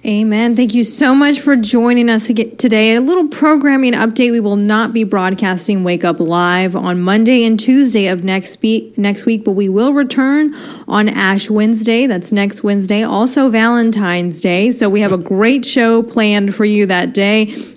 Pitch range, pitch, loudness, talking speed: 200-240 Hz, 220 Hz, -12 LUFS, 175 wpm